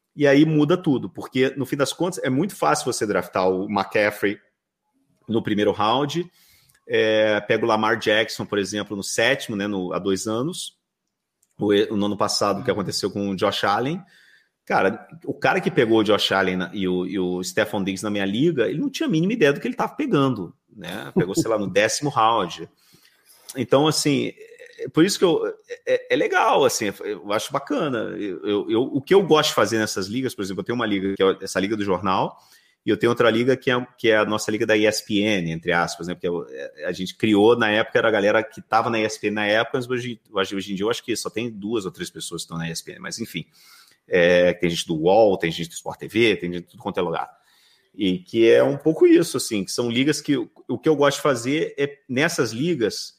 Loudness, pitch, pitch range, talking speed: -22 LUFS, 110 Hz, 100-145 Hz, 230 wpm